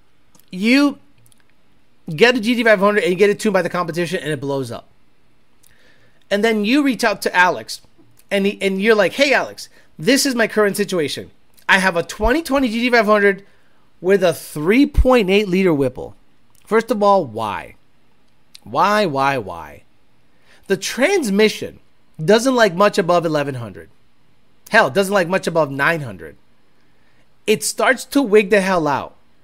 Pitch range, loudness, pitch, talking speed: 165-225 Hz, -17 LUFS, 200 Hz, 145 wpm